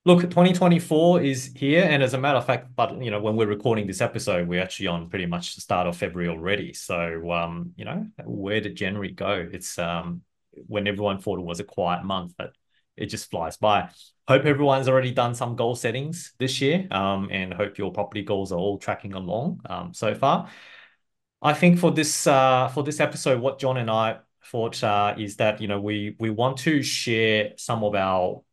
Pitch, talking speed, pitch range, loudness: 110 Hz, 210 wpm, 95-135 Hz, -24 LUFS